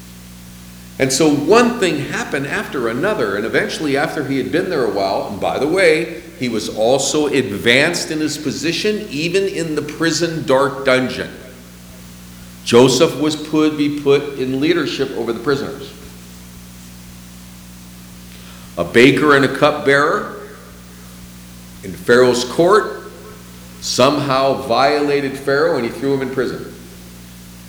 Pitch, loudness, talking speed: 120 Hz, -16 LUFS, 130 wpm